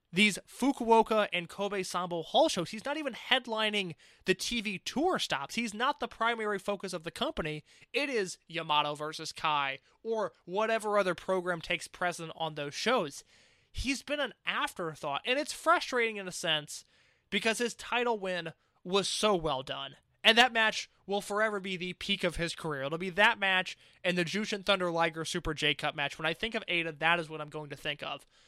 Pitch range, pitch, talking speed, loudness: 165-225 Hz, 190 Hz, 195 wpm, -31 LUFS